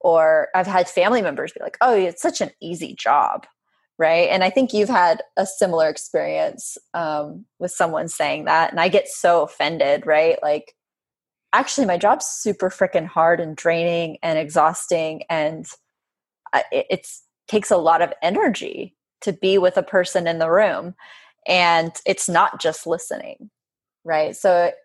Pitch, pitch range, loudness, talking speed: 175 Hz, 160-195 Hz, -19 LUFS, 160 wpm